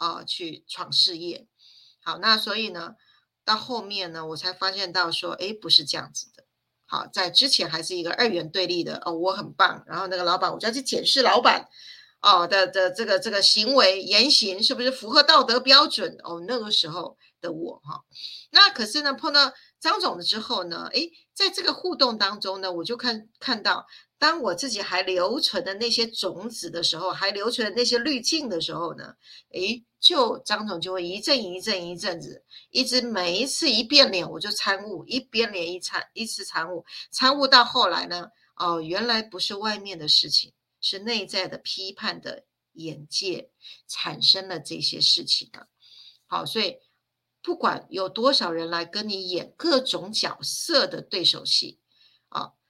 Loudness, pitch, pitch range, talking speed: -22 LUFS, 205 Hz, 180-250 Hz, 265 characters per minute